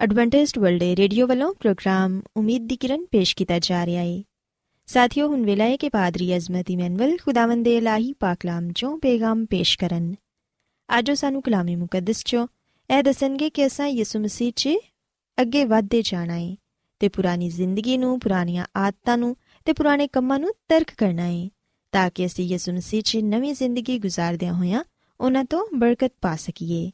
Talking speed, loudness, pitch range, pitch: 165 wpm, -22 LUFS, 180-260 Hz, 220 Hz